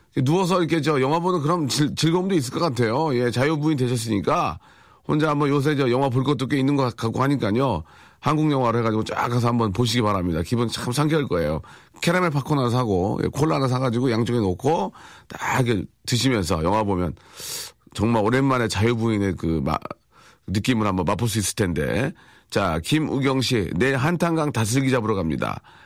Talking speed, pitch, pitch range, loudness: 370 characters per minute, 125 Hz, 110-145 Hz, -22 LUFS